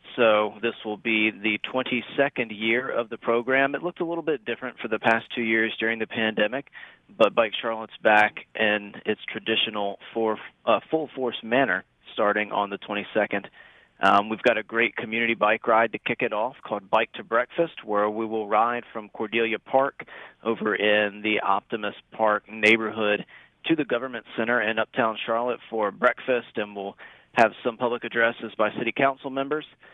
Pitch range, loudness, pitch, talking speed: 105-120 Hz, -25 LUFS, 110 Hz, 180 wpm